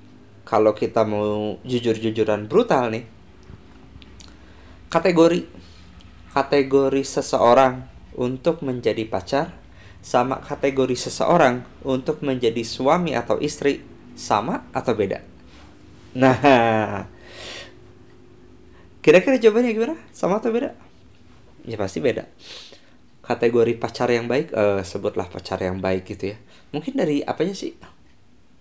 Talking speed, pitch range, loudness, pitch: 100 wpm, 105-135 Hz, -21 LUFS, 120 Hz